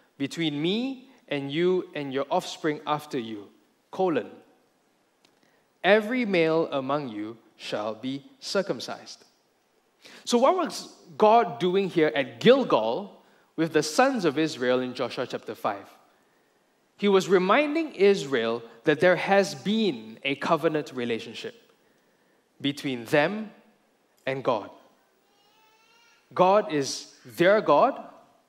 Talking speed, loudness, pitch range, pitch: 110 wpm, -25 LUFS, 140-210 Hz, 165 Hz